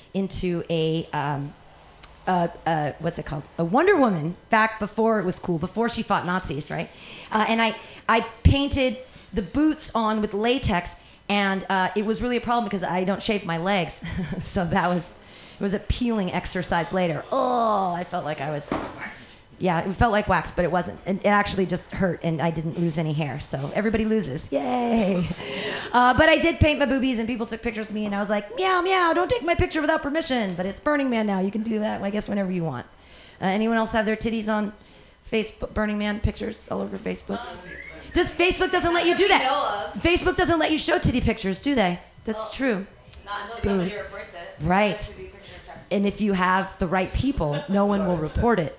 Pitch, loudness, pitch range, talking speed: 205 Hz, -24 LUFS, 180-230 Hz, 210 wpm